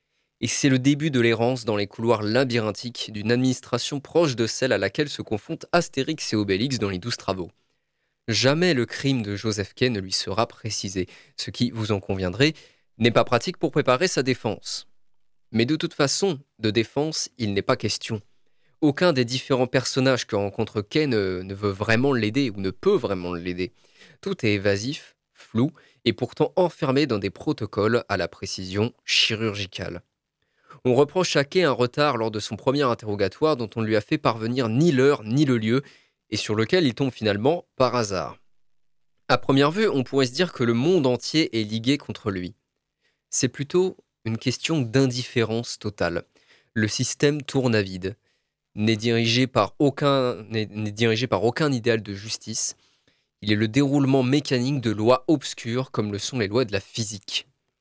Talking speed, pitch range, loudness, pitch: 180 wpm, 110-140 Hz, -24 LUFS, 120 Hz